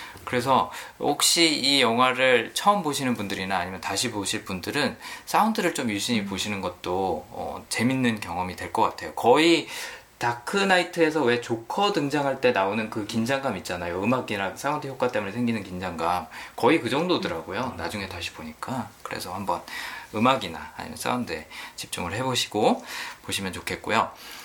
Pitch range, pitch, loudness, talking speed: 100-140 Hz, 120 Hz, -25 LUFS, 355 characters per minute